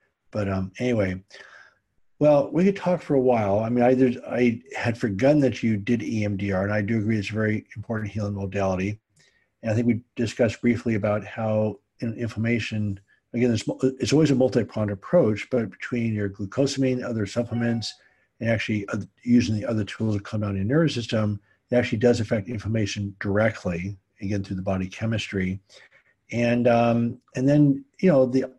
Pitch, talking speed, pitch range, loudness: 115 Hz, 175 wpm, 105-125 Hz, -24 LUFS